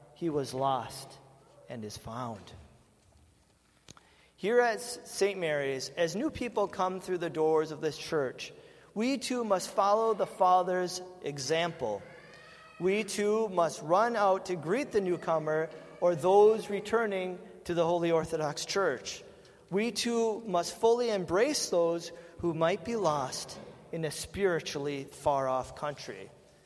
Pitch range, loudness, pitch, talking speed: 150-205 Hz, -30 LUFS, 170 Hz, 135 wpm